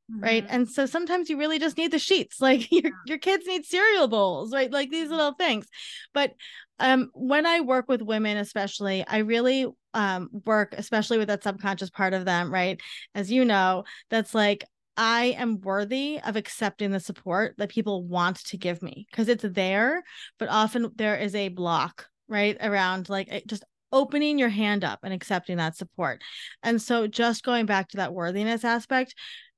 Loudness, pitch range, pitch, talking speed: -26 LUFS, 195-265 Hz, 220 Hz, 185 wpm